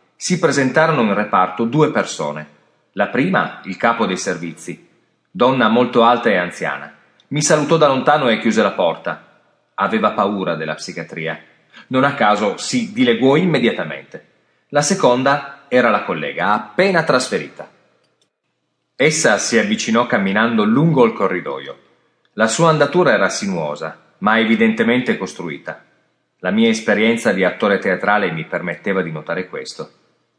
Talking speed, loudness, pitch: 135 wpm, -16 LUFS, 120 Hz